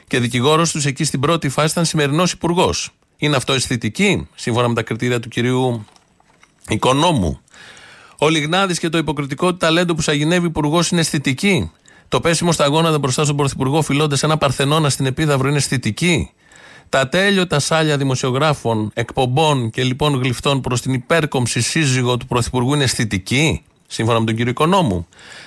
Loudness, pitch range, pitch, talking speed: -17 LUFS, 125-160 Hz, 145 Hz, 160 wpm